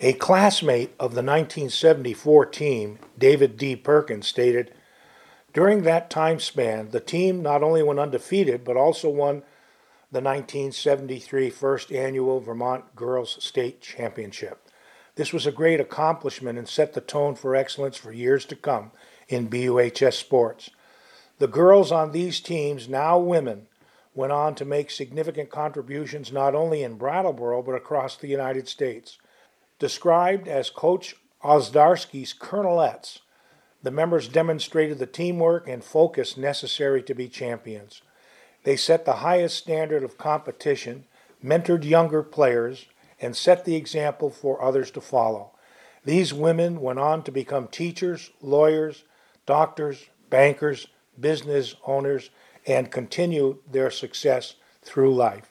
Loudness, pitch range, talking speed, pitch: -23 LUFS, 130-165 Hz, 135 wpm, 145 Hz